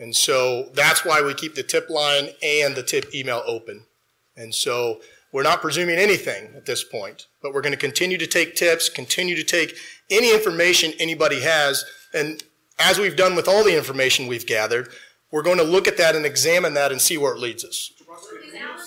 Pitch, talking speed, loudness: 165 Hz, 200 wpm, -19 LUFS